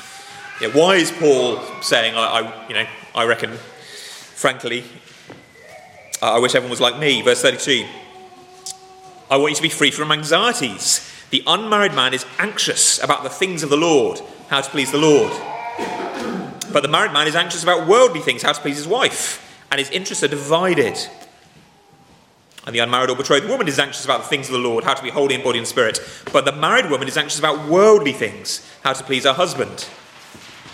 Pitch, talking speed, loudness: 155 Hz, 195 wpm, -17 LUFS